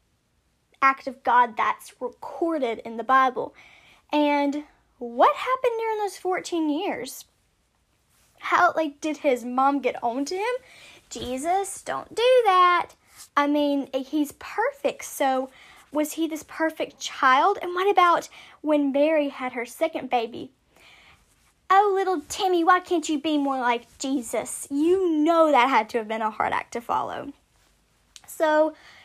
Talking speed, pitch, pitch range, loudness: 145 wpm, 305 Hz, 270-365 Hz, -24 LUFS